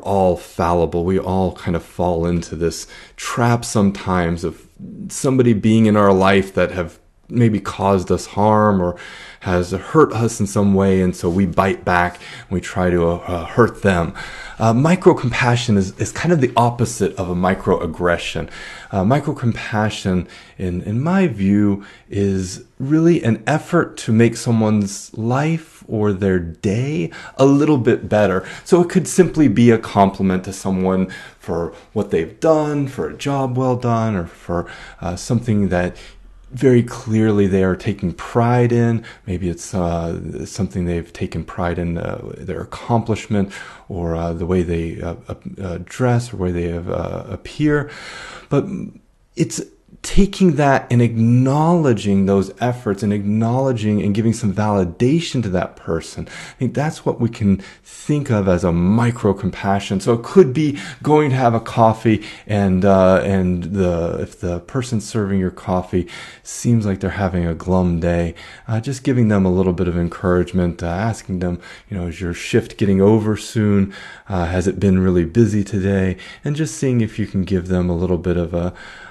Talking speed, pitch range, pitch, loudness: 170 wpm, 90-120 Hz, 100 Hz, -18 LUFS